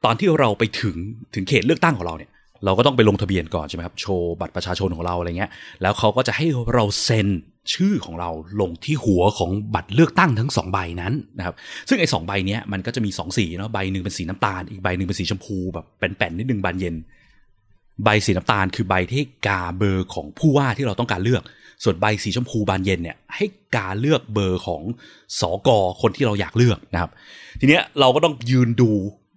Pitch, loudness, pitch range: 105 Hz, -21 LUFS, 95-120 Hz